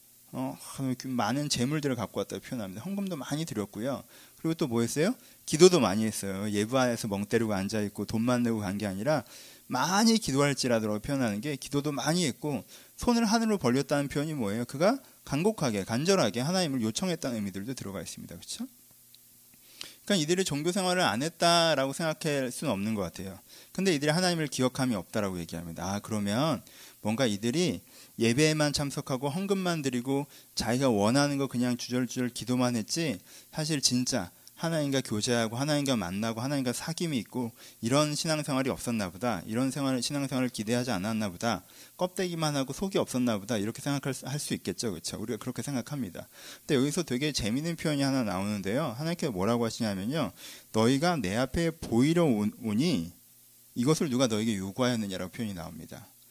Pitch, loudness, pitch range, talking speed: 130 Hz, -29 LUFS, 115-155 Hz, 415 characters per minute